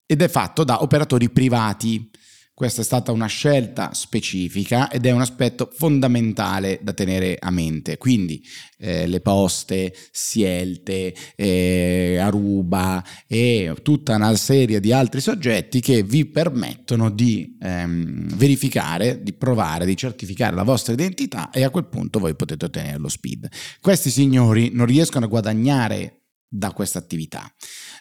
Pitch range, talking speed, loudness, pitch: 95-130 Hz, 140 wpm, -20 LUFS, 115 Hz